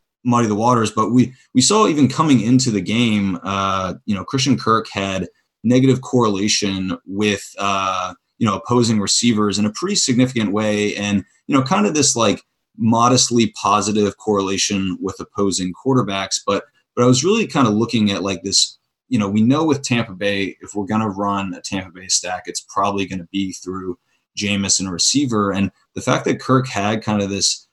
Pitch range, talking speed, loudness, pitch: 95-120 Hz, 190 wpm, -18 LUFS, 105 Hz